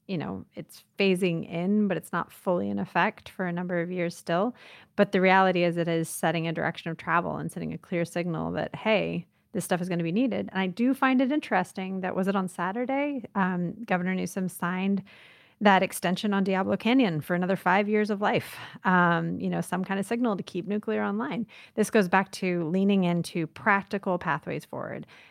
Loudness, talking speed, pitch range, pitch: -27 LUFS, 210 wpm, 175-205 Hz, 185 Hz